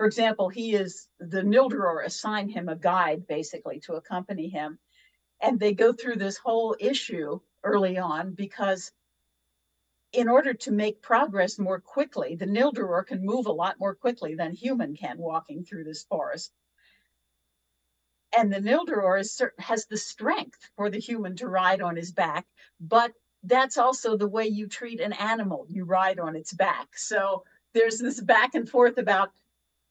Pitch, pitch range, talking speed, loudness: 195 Hz, 175-230 Hz, 165 wpm, -26 LUFS